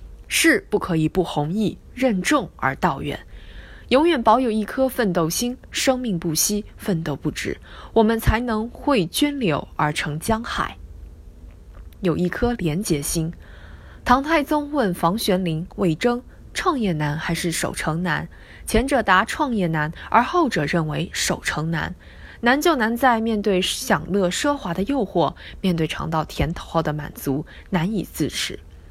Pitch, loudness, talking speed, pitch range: 180 Hz, -22 LUFS, 215 characters per minute, 155-235 Hz